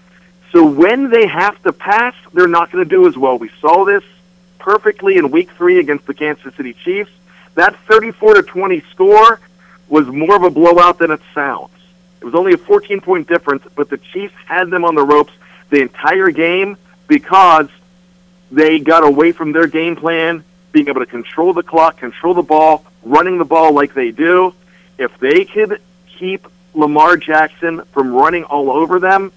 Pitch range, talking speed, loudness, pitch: 155-200 Hz, 185 wpm, -12 LUFS, 180 Hz